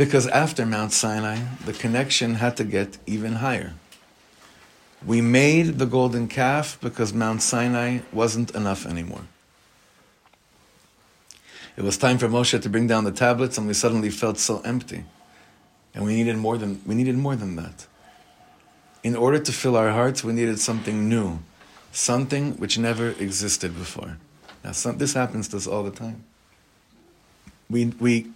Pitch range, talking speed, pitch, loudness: 105-125 Hz, 155 wpm, 115 Hz, -23 LUFS